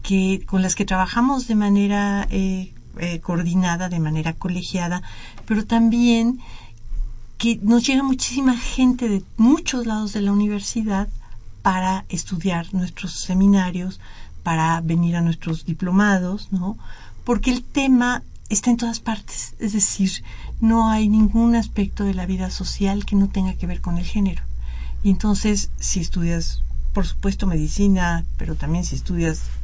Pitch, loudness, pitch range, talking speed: 190 Hz, -21 LUFS, 175-215 Hz, 145 wpm